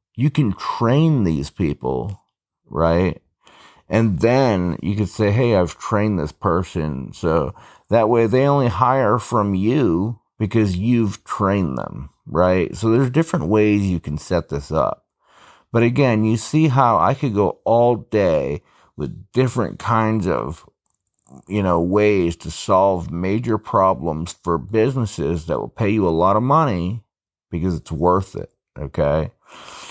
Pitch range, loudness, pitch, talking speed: 90-115 Hz, -19 LUFS, 105 Hz, 150 wpm